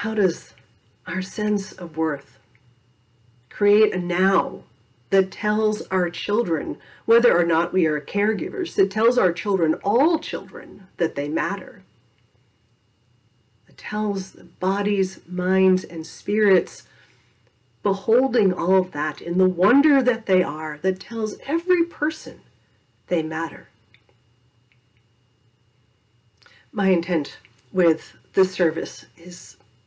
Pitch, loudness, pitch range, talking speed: 175 Hz, -22 LUFS, 120-205 Hz, 115 wpm